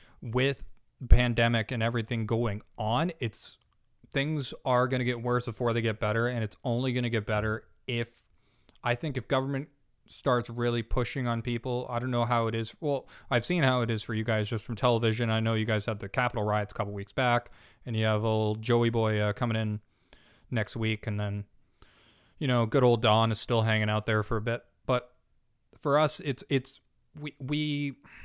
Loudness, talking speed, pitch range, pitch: -29 LUFS, 205 wpm, 110-125 Hz, 120 Hz